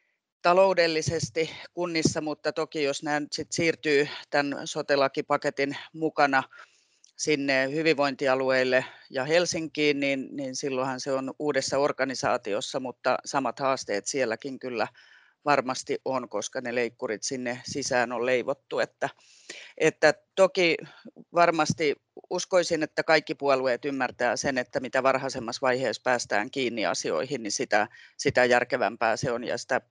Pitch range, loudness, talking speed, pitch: 130-160 Hz, -27 LUFS, 125 wpm, 145 Hz